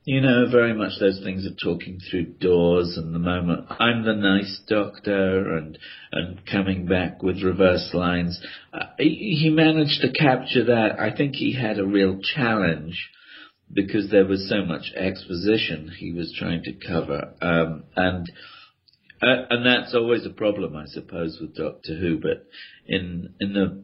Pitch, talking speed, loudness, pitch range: 95 Hz, 165 wpm, -23 LUFS, 85-110 Hz